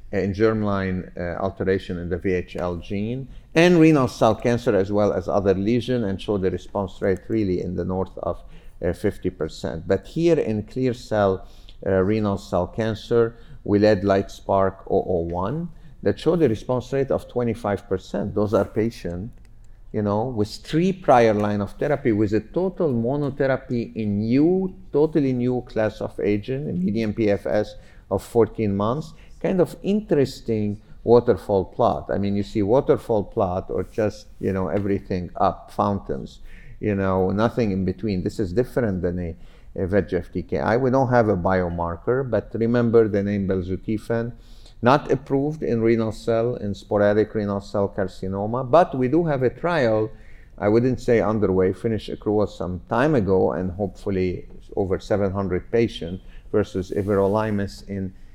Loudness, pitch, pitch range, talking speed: -23 LUFS, 105 Hz, 95-120 Hz, 155 wpm